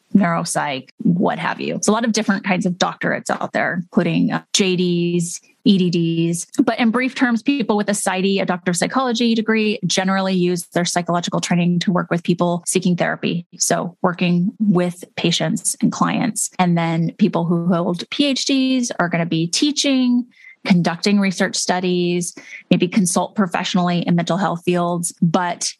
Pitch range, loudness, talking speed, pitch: 175-220 Hz, -18 LUFS, 160 wpm, 185 Hz